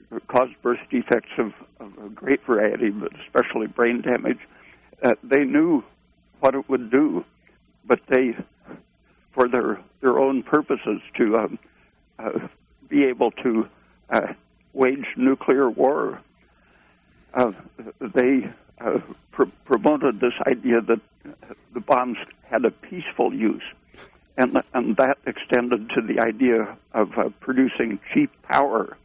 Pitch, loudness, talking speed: 120 Hz, -22 LUFS, 130 wpm